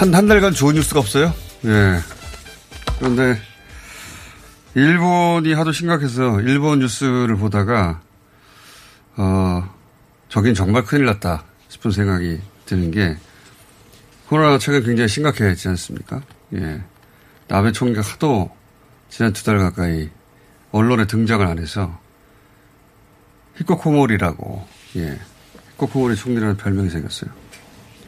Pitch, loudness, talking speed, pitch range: 110 Hz, -18 LUFS, 250 characters per minute, 95-135 Hz